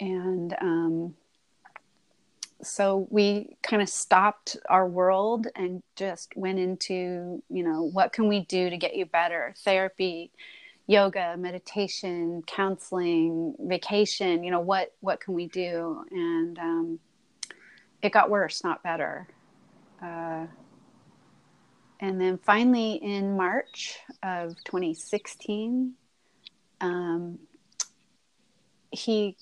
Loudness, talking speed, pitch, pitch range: -27 LUFS, 110 wpm, 190 Hz, 175-210 Hz